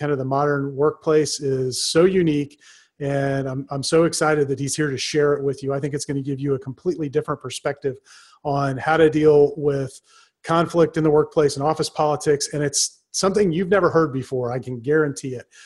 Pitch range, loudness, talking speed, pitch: 140-155 Hz, -21 LUFS, 205 wpm, 145 Hz